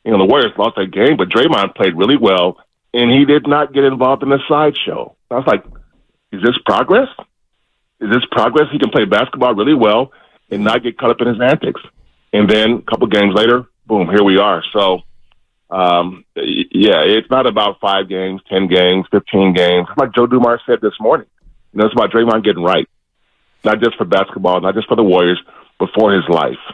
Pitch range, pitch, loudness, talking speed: 95-125 Hz, 110 Hz, -13 LUFS, 205 wpm